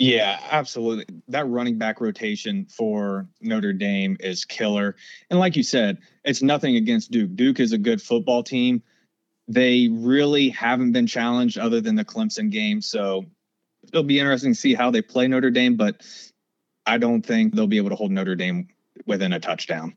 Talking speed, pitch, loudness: 180 wpm, 185 Hz, -22 LUFS